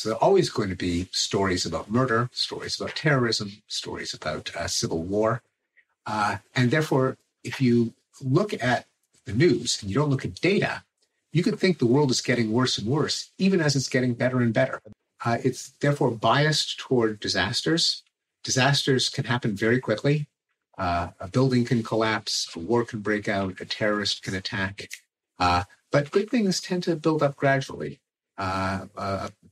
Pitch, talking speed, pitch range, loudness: 120 Hz, 175 wpm, 105-140 Hz, -25 LUFS